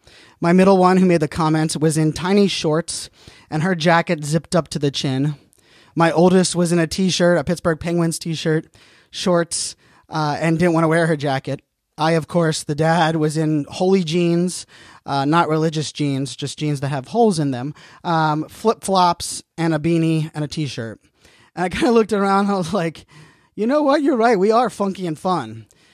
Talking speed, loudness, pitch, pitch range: 210 wpm, -19 LUFS, 165 Hz, 150-180 Hz